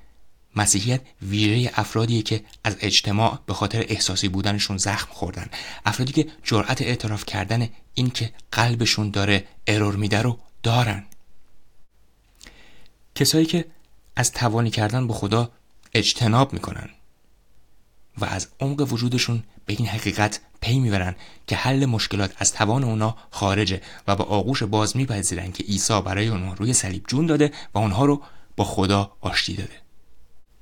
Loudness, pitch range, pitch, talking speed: -23 LUFS, 100-120 Hz, 110 Hz, 135 wpm